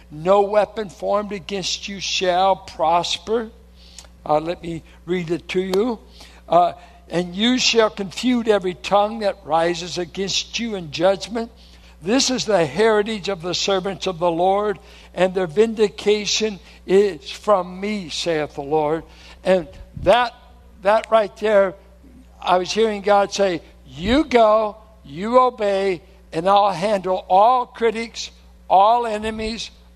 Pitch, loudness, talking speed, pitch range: 195 Hz, -20 LUFS, 135 wpm, 180-215 Hz